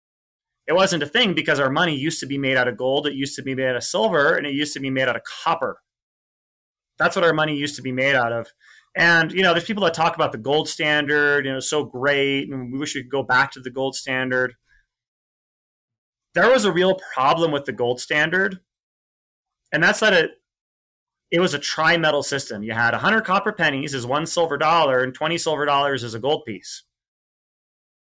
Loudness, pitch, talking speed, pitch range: -20 LUFS, 140 Hz, 220 wpm, 130-160 Hz